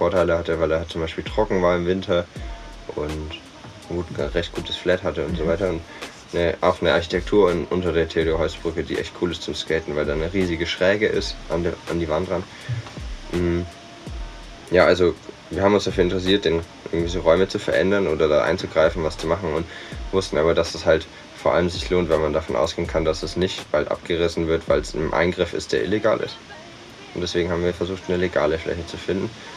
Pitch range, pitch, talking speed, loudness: 85-95 Hz, 85 Hz, 215 wpm, -22 LUFS